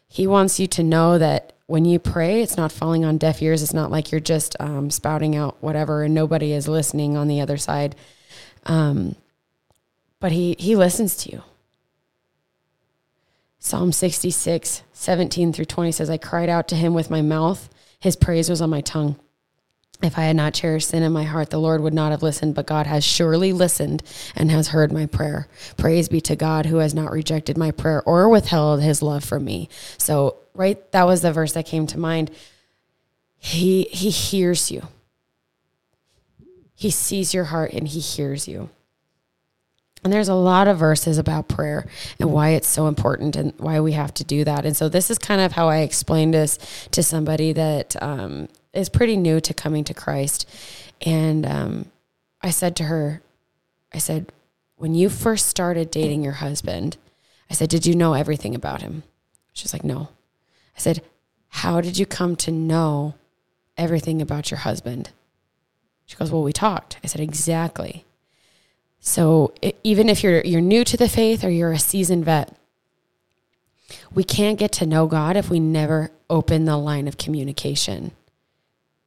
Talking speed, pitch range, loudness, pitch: 180 wpm, 150-170 Hz, -20 LUFS, 160 Hz